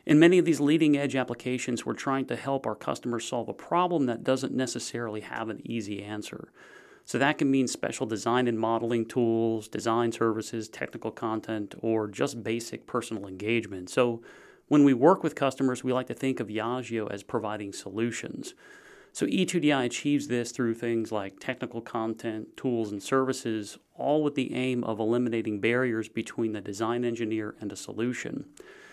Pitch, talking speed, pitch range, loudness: 120 Hz, 170 wpm, 110-130 Hz, -28 LUFS